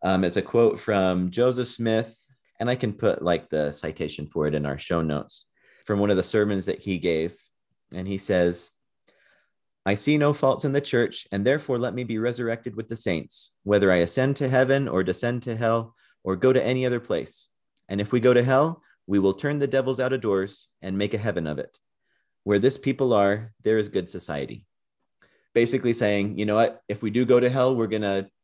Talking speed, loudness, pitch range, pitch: 215 wpm, -24 LUFS, 95-125 Hz, 110 Hz